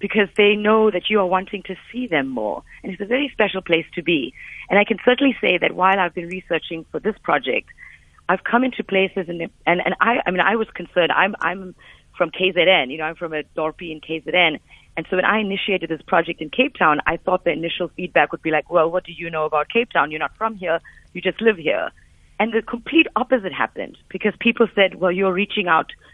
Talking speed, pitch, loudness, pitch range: 235 wpm, 185 Hz, -20 LUFS, 170-215 Hz